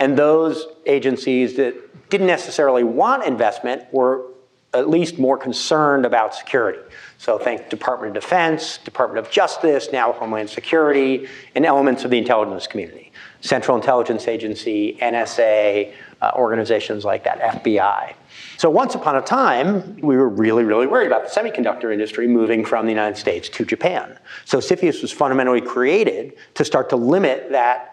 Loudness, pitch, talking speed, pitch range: -18 LUFS, 135 Hz, 155 wpm, 120-165 Hz